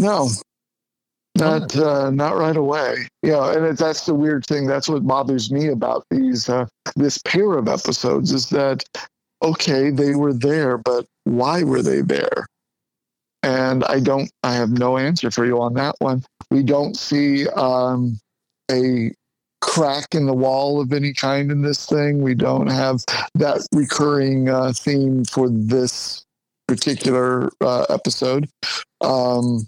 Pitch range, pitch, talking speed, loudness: 125-145 Hz, 135 Hz, 150 wpm, -19 LUFS